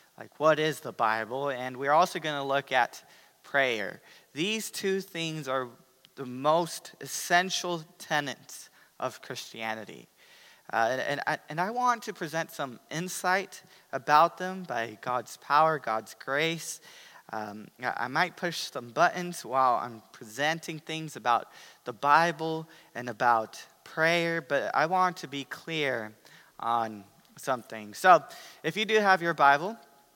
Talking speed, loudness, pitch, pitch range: 145 wpm, -28 LUFS, 160 Hz, 130-180 Hz